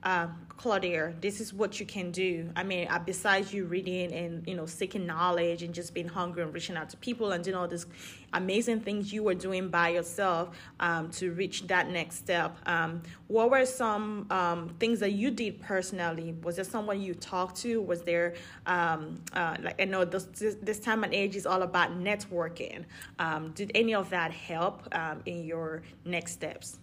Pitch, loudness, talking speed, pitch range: 185 Hz, -31 LUFS, 195 wpm, 170-200 Hz